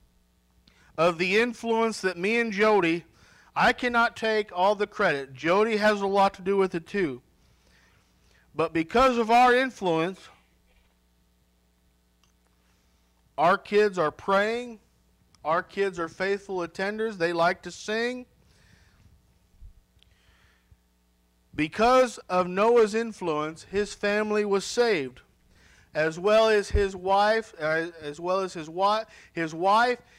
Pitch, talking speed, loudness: 175 Hz, 120 wpm, -25 LUFS